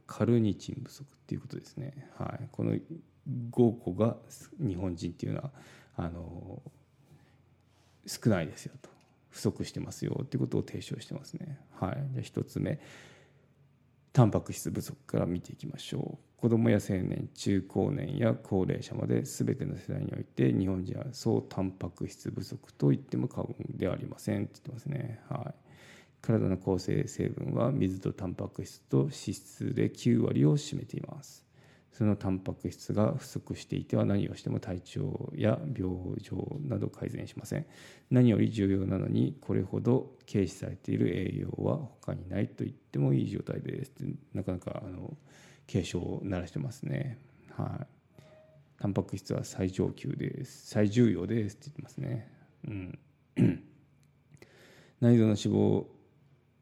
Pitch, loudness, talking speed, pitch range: 120 Hz, -32 LUFS, 305 characters per minute, 100-140 Hz